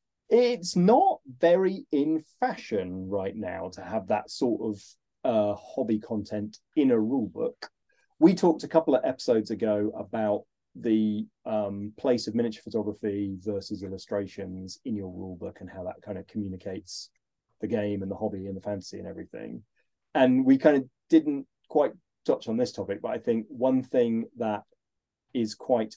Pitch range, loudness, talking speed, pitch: 105-160 Hz, -28 LUFS, 170 wpm, 110 Hz